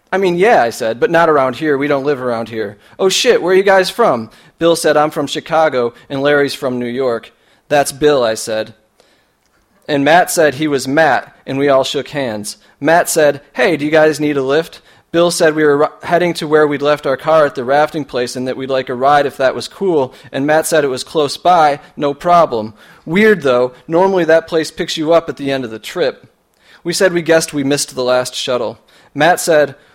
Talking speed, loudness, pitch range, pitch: 230 wpm, -14 LUFS, 130-160 Hz, 150 Hz